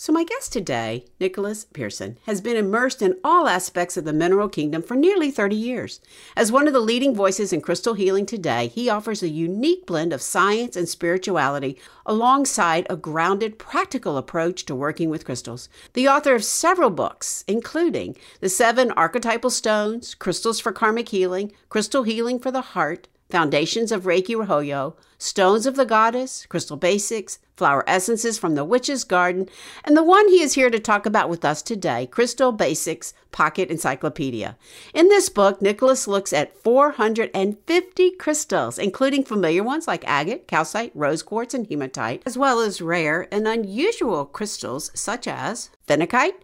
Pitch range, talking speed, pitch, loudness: 175-255 Hz, 165 wpm, 215 Hz, -21 LUFS